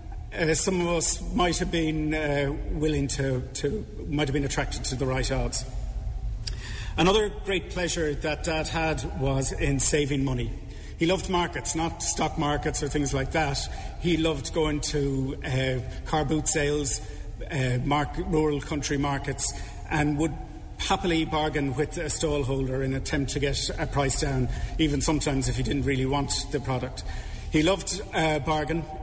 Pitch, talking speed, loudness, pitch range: 145 Hz, 165 wpm, -26 LUFS, 135-155 Hz